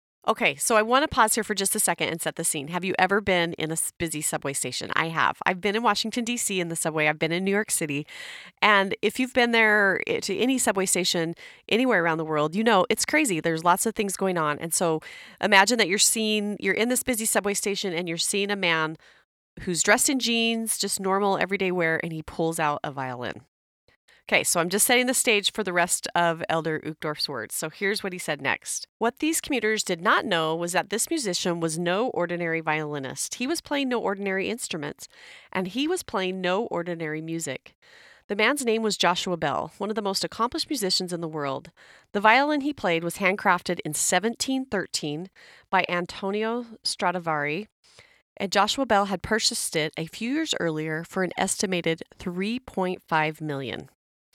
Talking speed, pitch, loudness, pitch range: 200 wpm, 190 Hz, -24 LUFS, 165-220 Hz